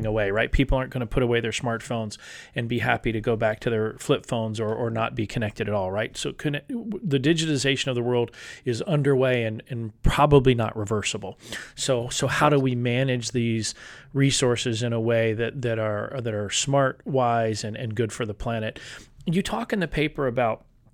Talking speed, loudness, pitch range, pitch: 205 wpm, -25 LUFS, 115-135 Hz, 120 Hz